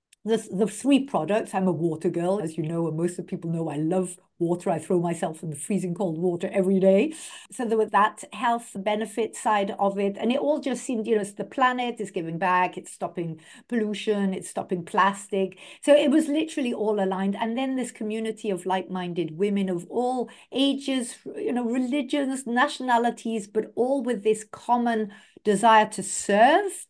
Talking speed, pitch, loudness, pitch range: 195 wpm, 210 Hz, -25 LUFS, 185-240 Hz